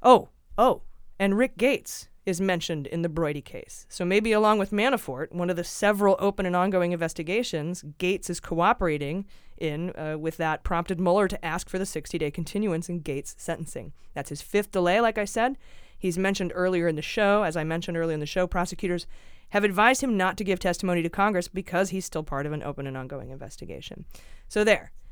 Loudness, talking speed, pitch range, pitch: -26 LUFS, 205 wpm, 160-200 Hz, 180 Hz